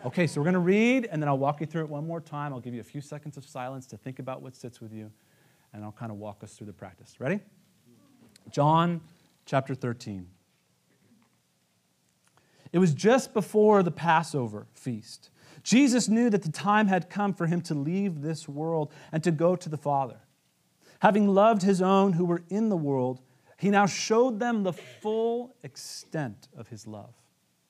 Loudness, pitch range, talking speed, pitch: -26 LUFS, 125-190 Hz, 195 wpm, 155 Hz